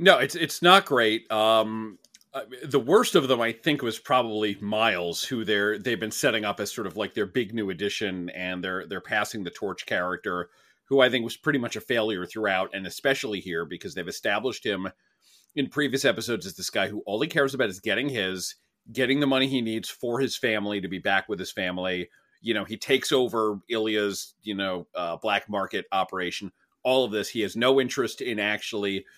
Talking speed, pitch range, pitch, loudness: 210 wpm, 95-125 Hz, 110 Hz, -26 LUFS